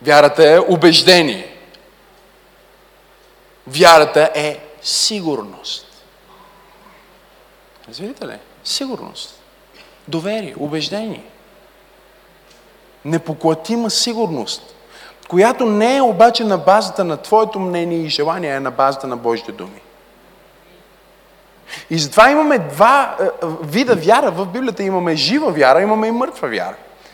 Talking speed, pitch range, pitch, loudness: 100 wpm, 155-220 Hz, 180 Hz, -14 LUFS